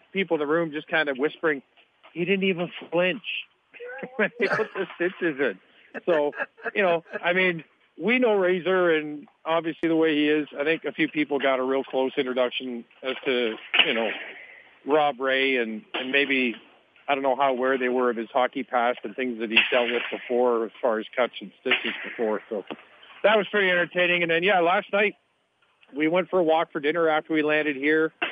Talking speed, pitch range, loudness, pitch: 205 wpm, 130-175 Hz, -24 LUFS, 155 Hz